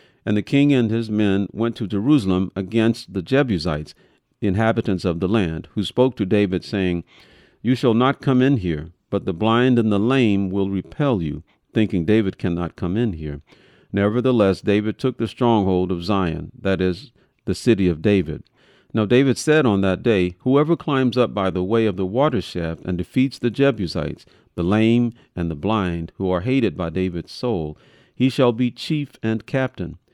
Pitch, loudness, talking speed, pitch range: 105 Hz, -20 LUFS, 185 wpm, 90-125 Hz